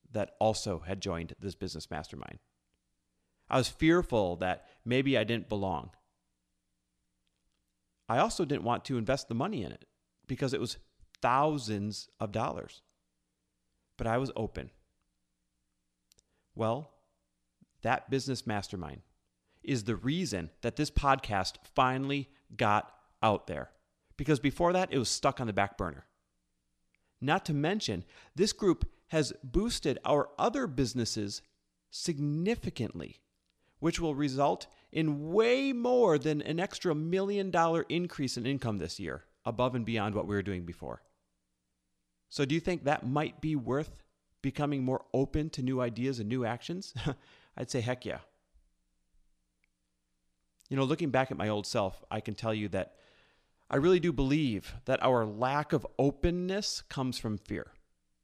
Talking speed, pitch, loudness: 145 wpm, 115 Hz, -32 LUFS